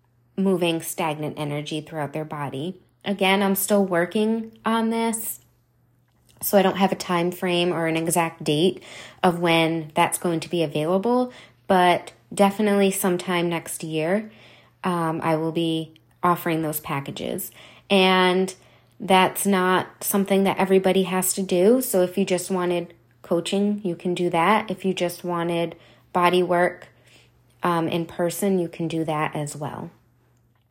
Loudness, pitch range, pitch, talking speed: -23 LUFS, 160-190 Hz, 175 Hz, 150 wpm